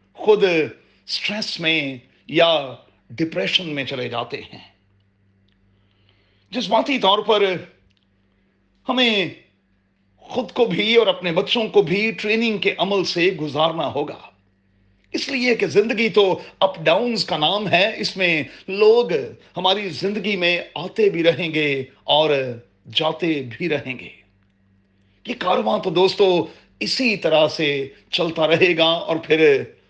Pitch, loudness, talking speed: 170 Hz, -19 LUFS, 130 wpm